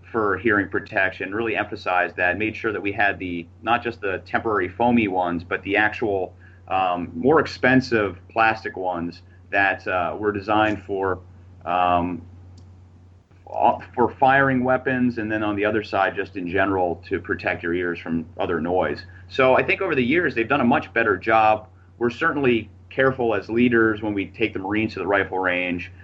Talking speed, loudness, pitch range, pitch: 175 wpm, -22 LUFS, 90-110 Hz, 100 Hz